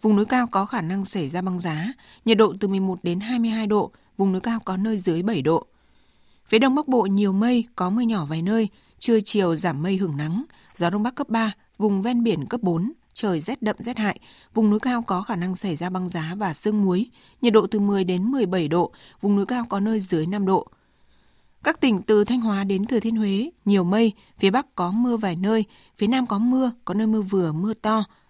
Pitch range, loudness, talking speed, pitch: 185-225 Hz, -23 LUFS, 240 wpm, 205 Hz